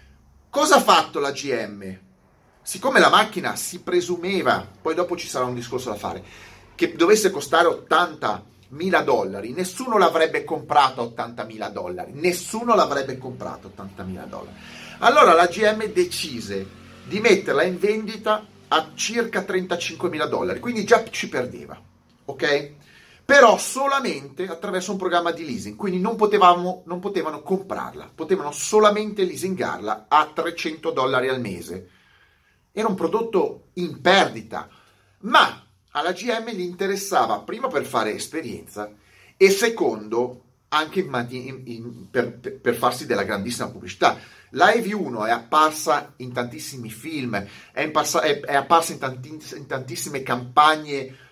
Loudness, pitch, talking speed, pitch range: -21 LUFS, 165 Hz, 135 wpm, 125-190 Hz